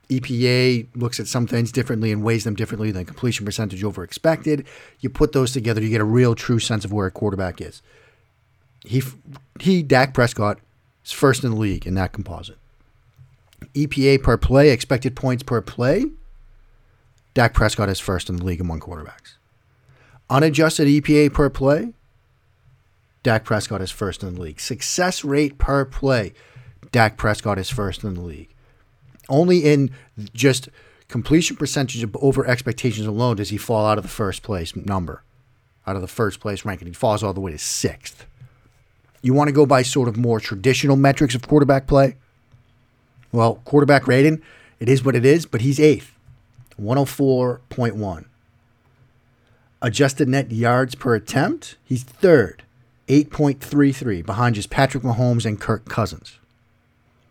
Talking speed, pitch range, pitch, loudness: 160 wpm, 110-130 Hz, 120 Hz, -20 LUFS